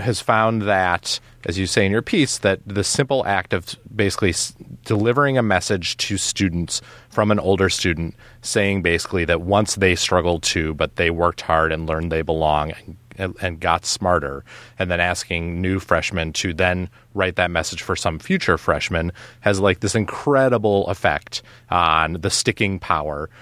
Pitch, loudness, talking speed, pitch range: 95 Hz, -20 LUFS, 170 wpm, 85-105 Hz